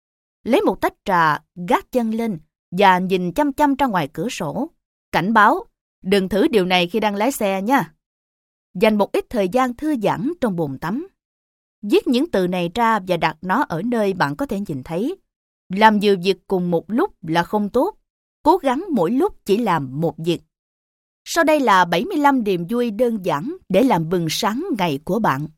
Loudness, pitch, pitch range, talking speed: -19 LUFS, 205 Hz, 175-260 Hz, 195 wpm